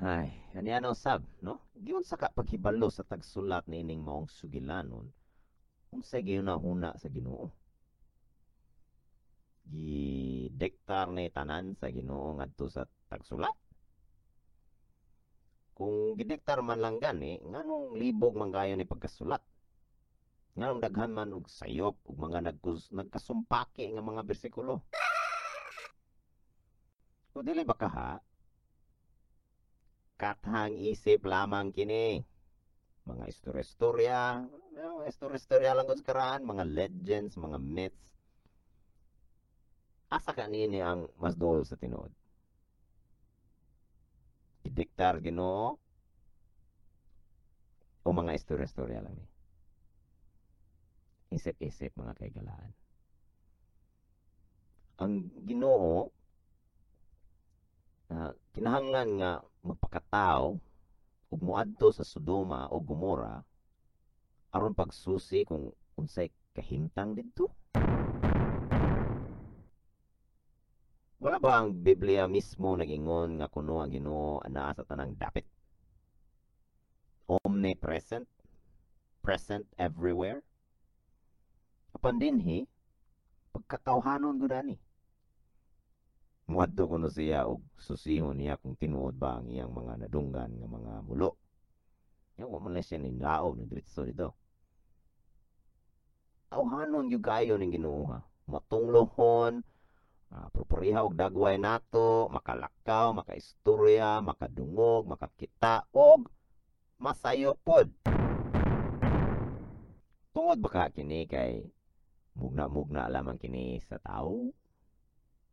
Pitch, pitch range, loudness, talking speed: 95 Hz, 80-115 Hz, -32 LUFS, 95 wpm